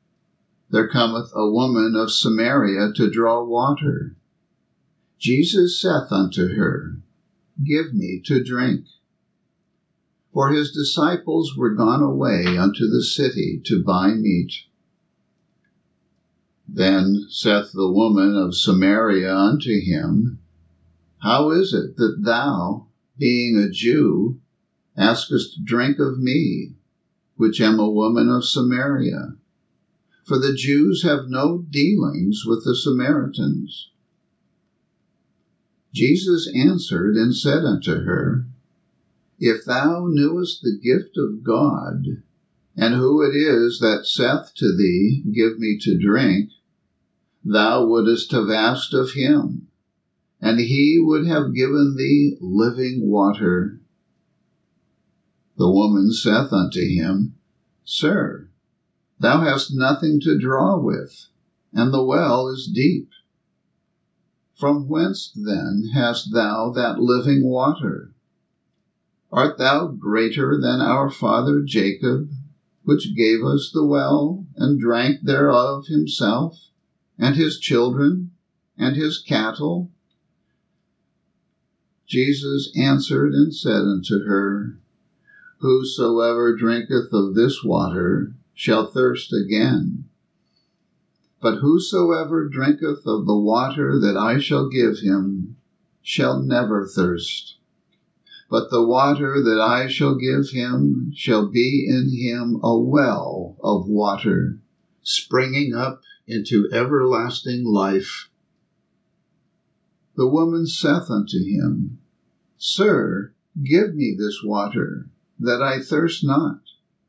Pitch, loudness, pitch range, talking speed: 125 Hz, -19 LUFS, 110-145 Hz, 110 wpm